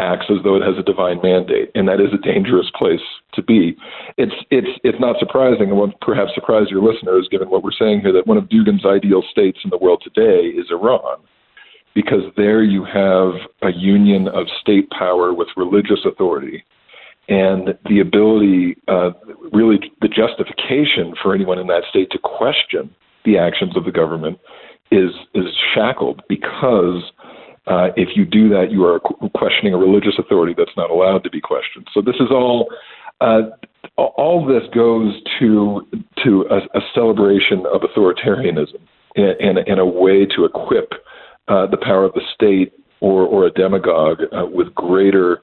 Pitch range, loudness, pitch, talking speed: 95-115 Hz, -15 LUFS, 100 Hz, 175 wpm